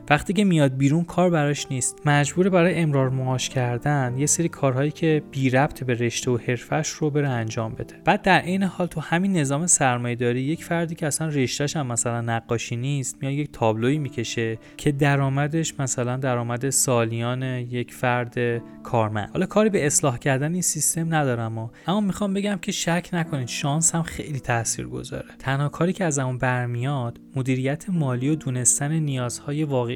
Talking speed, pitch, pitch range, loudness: 170 wpm, 140 Hz, 125-160 Hz, -23 LUFS